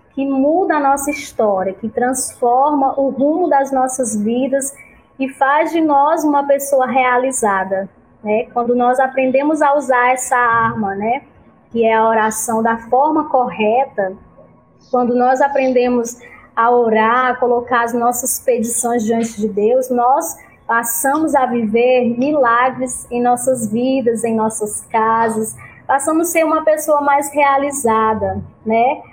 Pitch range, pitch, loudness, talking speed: 230-275 Hz, 250 Hz, -15 LUFS, 140 wpm